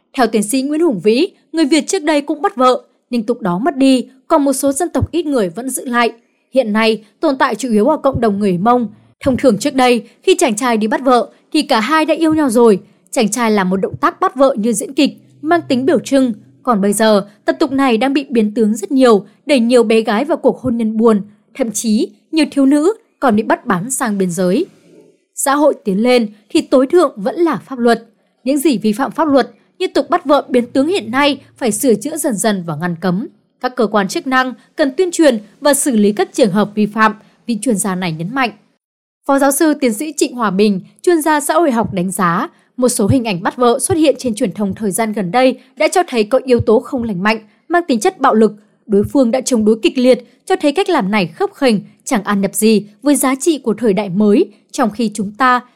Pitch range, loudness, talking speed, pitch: 215-290 Hz, -14 LUFS, 250 wpm, 250 Hz